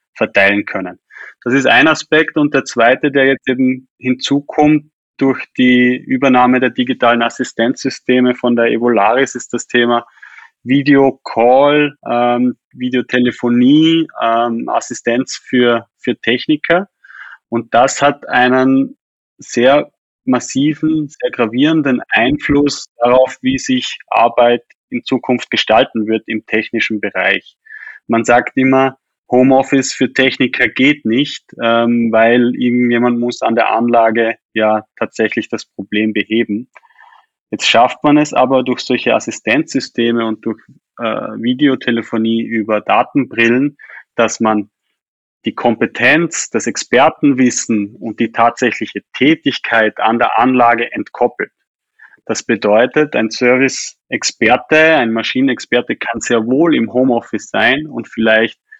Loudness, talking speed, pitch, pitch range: -13 LUFS, 115 wpm, 125 Hz, 115-135 Hz